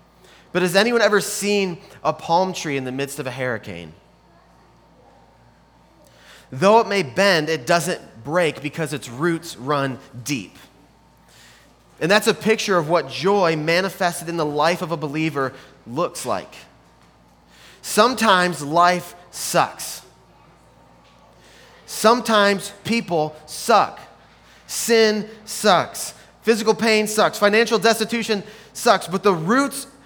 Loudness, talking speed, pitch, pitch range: -20 LUFS, 120 wpm, 175 Hz, 140-210 Hz